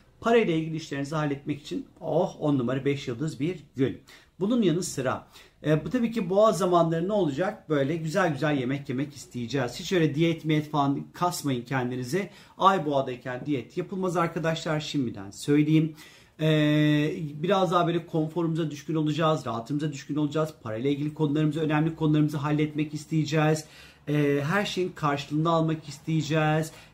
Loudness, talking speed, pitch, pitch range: -27 LUFS, 145 wpm, 155 Hz, 145-165 Hz